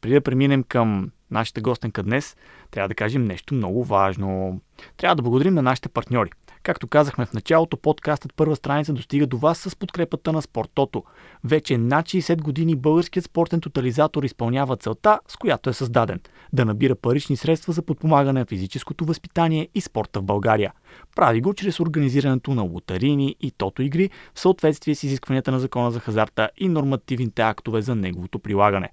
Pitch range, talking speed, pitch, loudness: 115-155 Hz, 170 wpm, 135 Hz, -22 LUFS